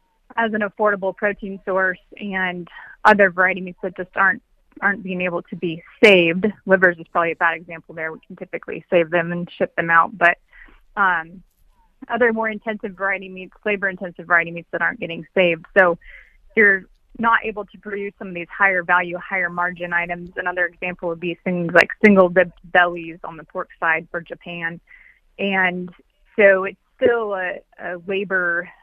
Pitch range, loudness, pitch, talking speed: 175-200 Hz, -19 LUFS, 185 Hz, 175 wpm